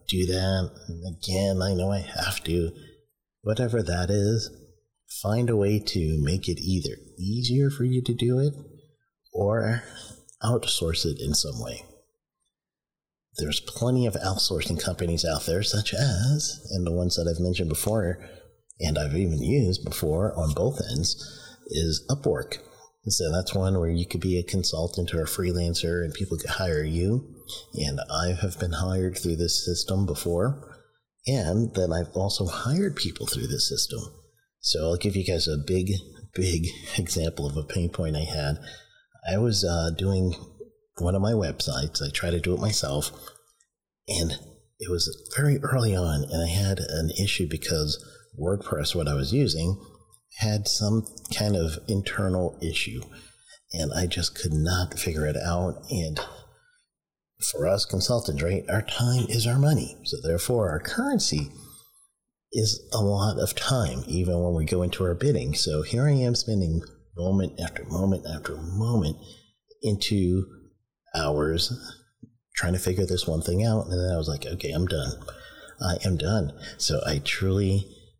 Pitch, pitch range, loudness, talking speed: 95 Hz, 85-110 Hz, -26 LUFS, 160 wpm